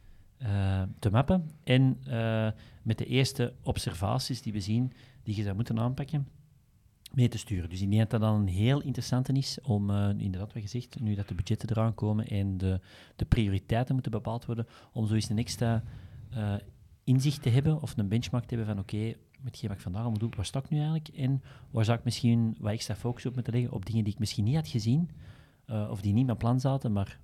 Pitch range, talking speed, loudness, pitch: 105-125 Hz, 225 wpm, -31 LUFS, 115 Hz